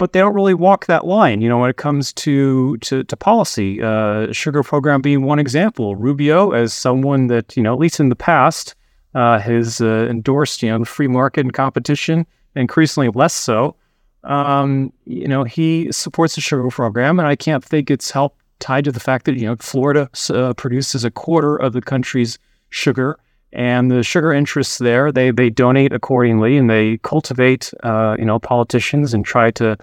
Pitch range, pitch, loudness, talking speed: 120-145 Hz, 130 Hz, -16 LUFS, 195 wpm